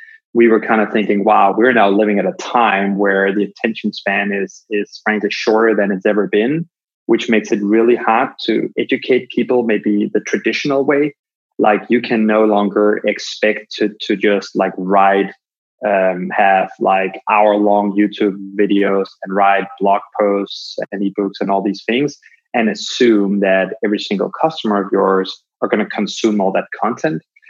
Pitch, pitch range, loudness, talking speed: 105 Hz, 100-110 Hz, -15 LUFS, 170 wpm